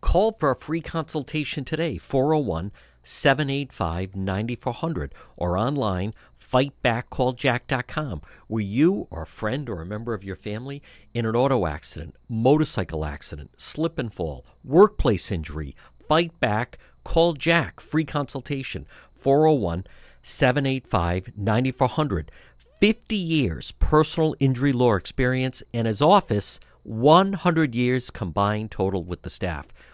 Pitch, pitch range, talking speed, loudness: 125 Hz, 95-145 Hz, 120 wpm, -24 LUFS